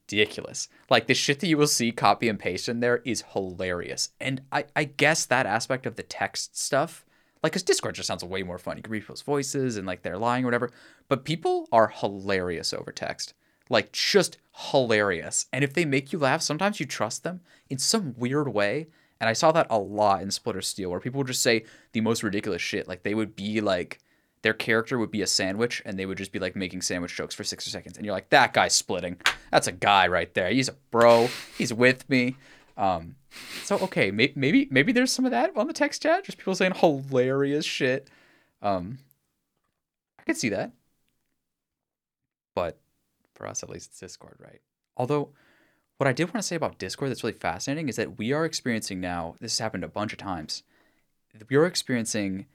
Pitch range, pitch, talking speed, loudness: 105-145 Hz, 125 Hz, 210 wpm, -26 LUFS